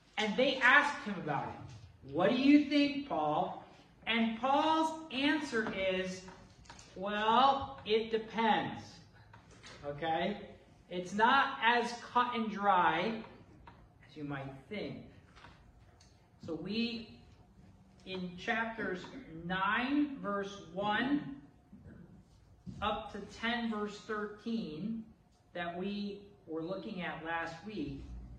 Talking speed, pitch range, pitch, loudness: 100 wpm, 175-230 Hz, 210 Hz, -33 LUFS